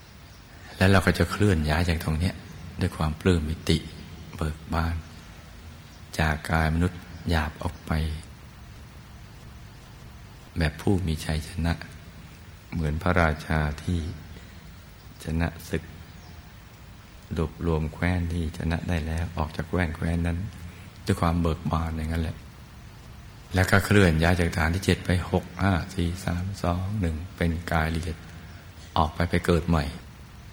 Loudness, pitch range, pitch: -27 LUFS, 80-90 Hz, 85 Hz